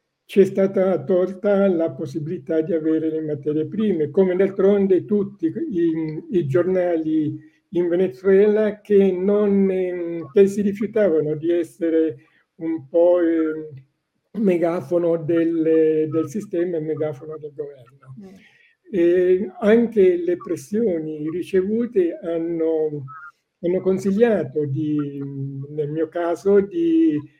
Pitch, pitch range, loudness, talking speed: 170 Hz, 155-195 Hz, -20 LUFS, 105 wpm